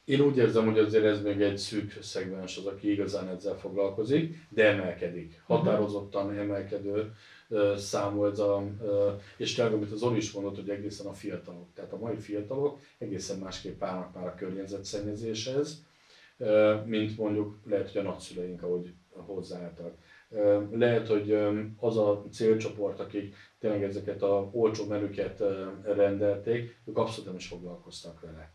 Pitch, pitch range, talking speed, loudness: 100 Hz, 100-110 Hz, 140 wpm, -30 LUFS